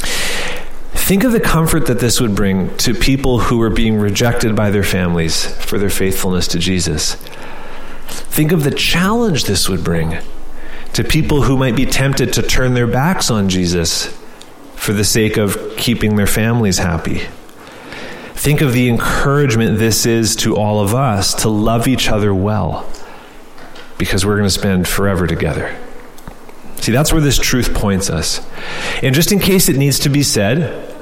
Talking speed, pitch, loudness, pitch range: 170 wpm, 110 Hz, -15 LUFS, 100-135 Hz